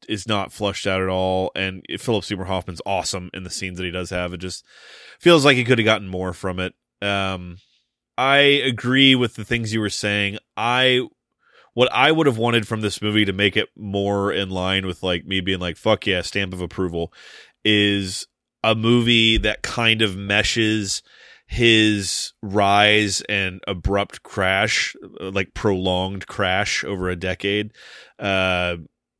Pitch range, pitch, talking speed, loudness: 95-110 Hz, 100 Hz, 170 wpm, -20 LUFS